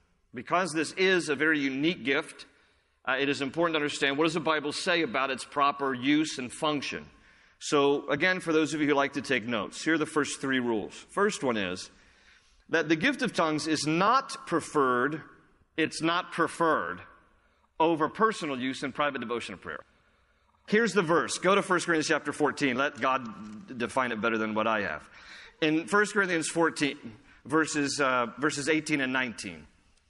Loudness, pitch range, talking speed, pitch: -28 LUFS, 135-165 Hz, 180 wpm, 150 Hz